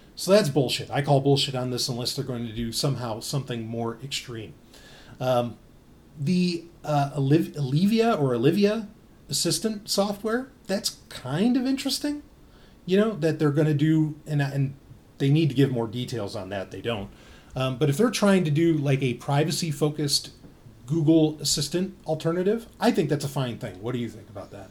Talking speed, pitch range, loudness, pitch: 180 wpm, 125-170 Hz, -25 LUFS, 145 Hz